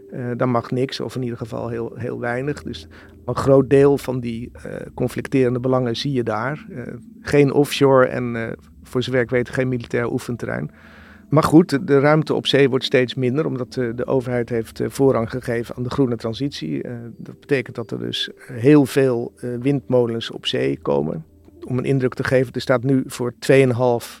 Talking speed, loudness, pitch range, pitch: 200 wpm, -20 LUFS, 120-135 Hz, 125 Hz